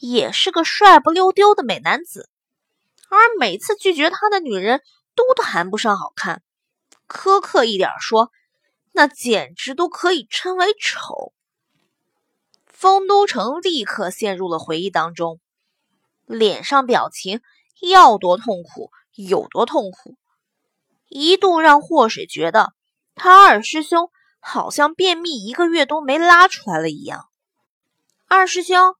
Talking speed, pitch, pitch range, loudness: 190 characters per minute, 315 Hz, 225-375 Hz, -15 LUFS